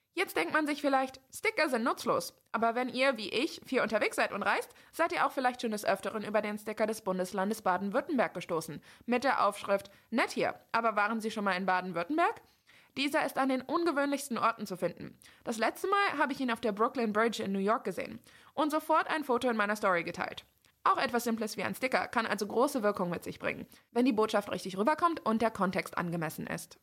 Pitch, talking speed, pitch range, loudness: 230 Hz, 215 wpm, 205-275 Hz, -32 LUFS